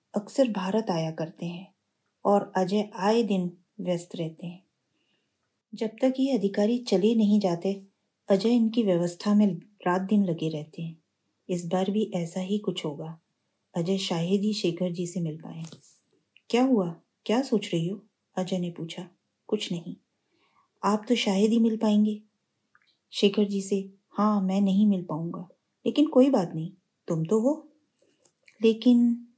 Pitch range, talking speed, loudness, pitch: 180-220 Hz, 155 wpm, -27 LUFS, 200 Hz